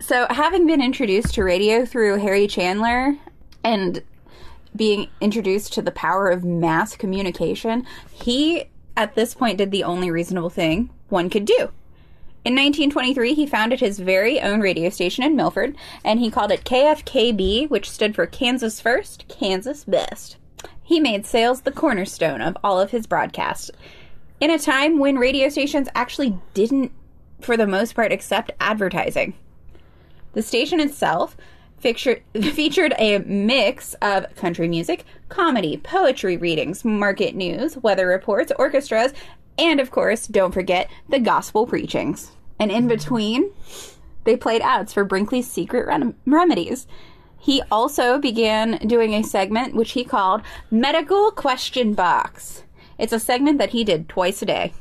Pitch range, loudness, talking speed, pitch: 200-275 Hz, -20 LUFS, 150 wpm, 235 Hz